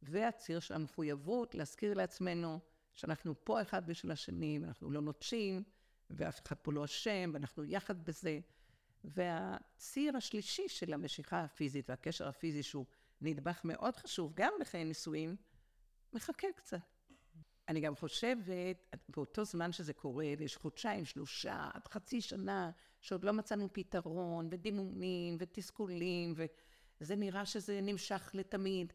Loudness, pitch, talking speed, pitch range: -42 LUFS, 170 Hz, 125 wpm, 155-200 Hz